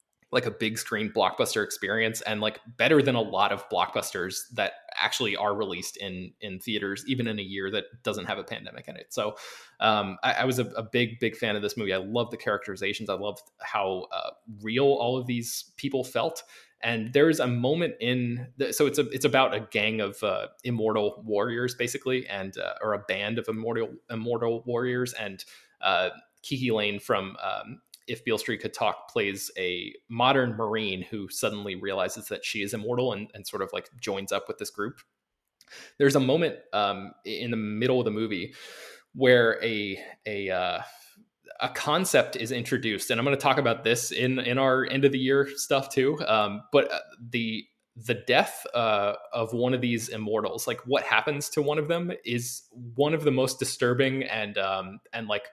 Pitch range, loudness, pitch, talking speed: 105-130 Hz, -27 LUFS, 120 Hz, 195 wpm